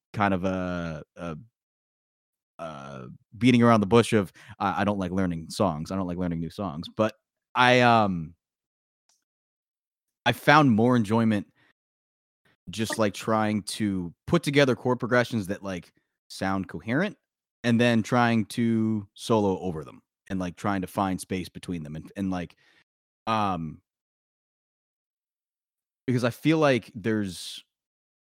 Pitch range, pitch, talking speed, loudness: 90-115 Hz, 105 Hz, 140 wpm, -25 LUFS